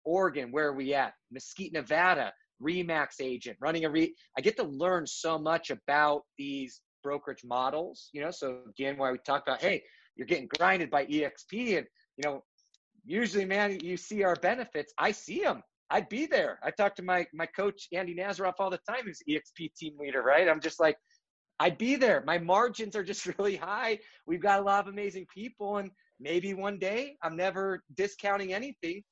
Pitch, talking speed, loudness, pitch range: 180 Hz, 195 wpm, -31 LUFS, 150-200 Hz